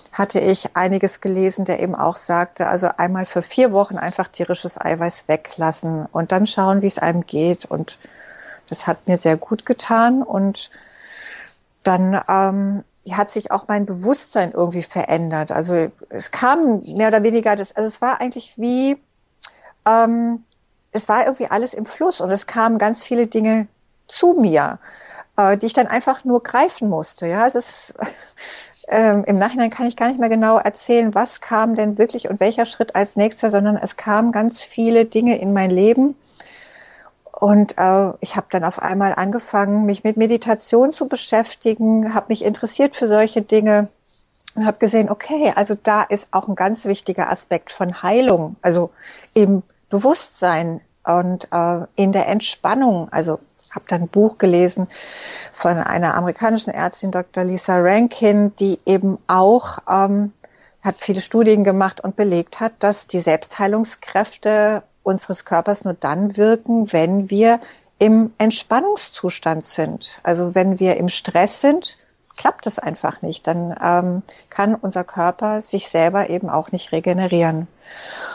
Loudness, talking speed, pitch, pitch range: -18 LUFS, 155 wpm, 200 Hz, 180-225 Hz